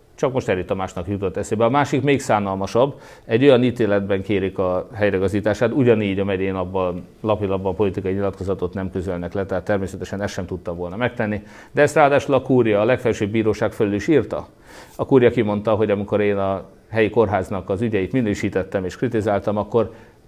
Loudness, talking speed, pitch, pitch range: -20 LUFS, 175 wpm, 105 Hz, 95-115 Hz